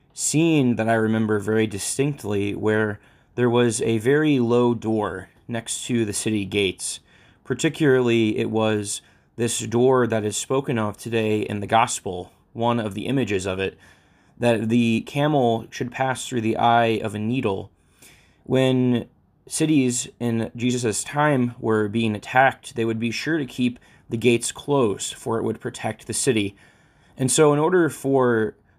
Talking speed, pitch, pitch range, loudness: 160 wpm, 115 Hz, 110-130 Hz, -22 LUFS